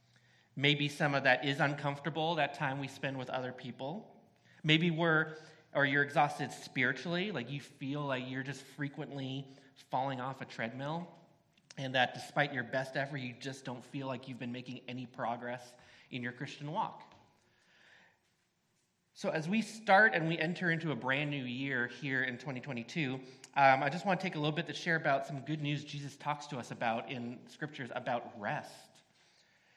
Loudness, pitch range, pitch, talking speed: -35 LUFS, 130-150 Hz, 140 Hz, 180 wpm